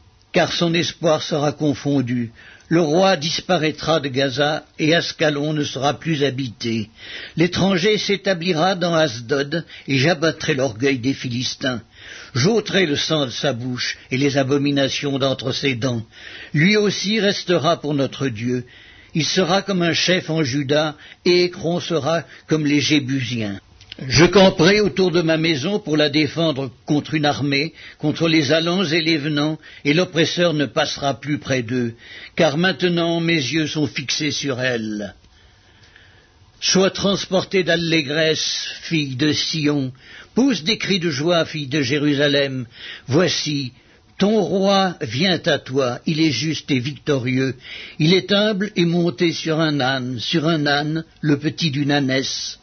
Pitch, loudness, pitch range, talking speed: 150 Hz, -19 LUFS, 135-170 Hz, 145 wpm